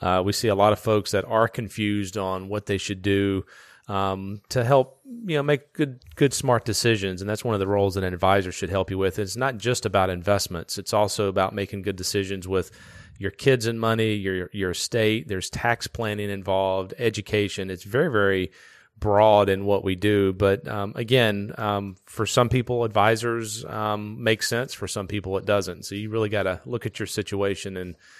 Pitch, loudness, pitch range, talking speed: 105 Hz, -24 LUFS, 95-115 Hz, 205 wpm